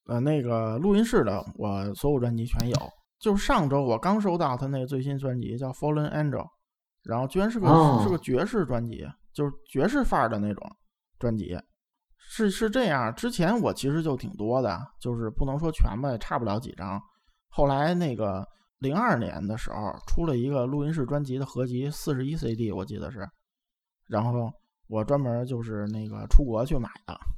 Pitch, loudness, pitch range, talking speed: 130 Hz, -27 LUFS, 115-160 Hz, 300 characters per minute